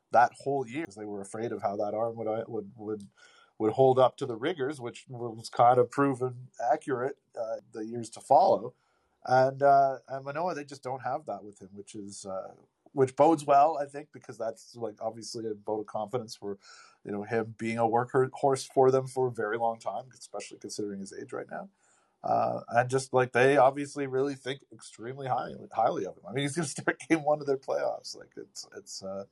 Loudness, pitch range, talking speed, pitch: -29 LUFS, 110-135 Hz, 220 wpm, 125 Hz